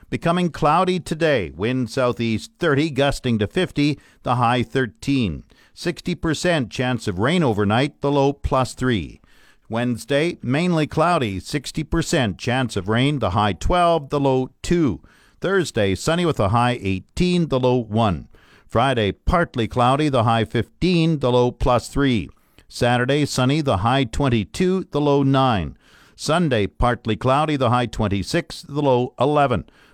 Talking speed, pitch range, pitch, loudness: 140 wpm, 115-150 Hz, 130 Hz, -20 LUFS